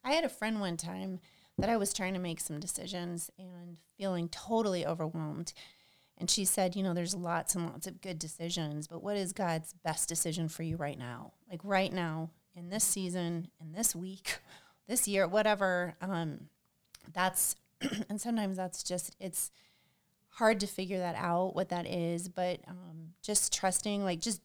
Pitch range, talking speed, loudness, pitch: 170-195 Hz, 180 wpm, -34 LUFS, 180 Hz